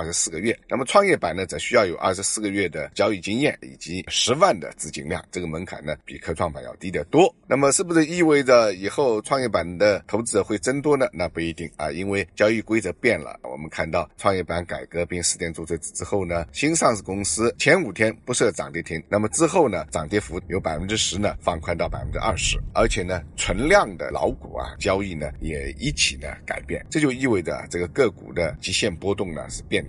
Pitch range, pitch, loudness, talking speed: 85-105 Hz, 90 Hz, -23 LUFS, 335 characters per minute